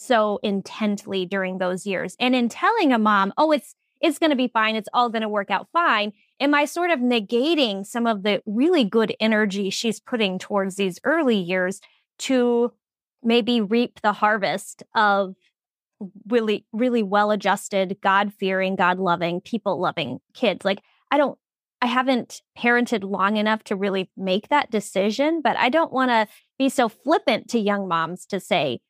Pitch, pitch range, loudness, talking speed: 215 Hz, 195-250 Hz, -22 LUFS, 165 wpm